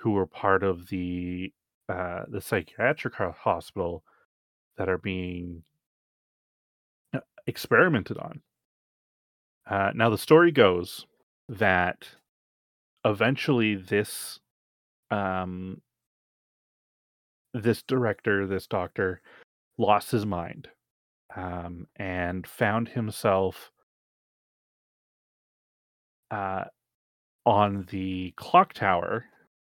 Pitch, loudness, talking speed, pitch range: 95 Hz, -27 LUFS, 80 wpm, 90-105 Hz